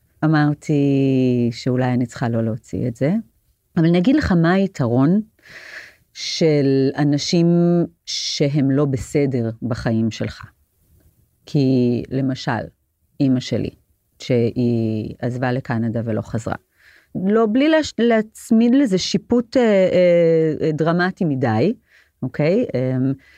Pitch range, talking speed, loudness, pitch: 120-170 Hz, 100 wpm, -19 LUFS, 135 Hz